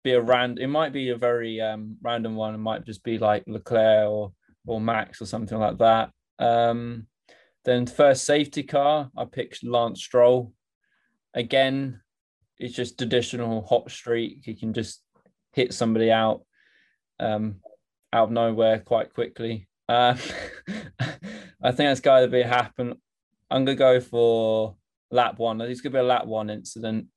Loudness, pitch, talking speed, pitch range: -24 LUFS, 115 Hz, 155 wpm, 110-125 Hz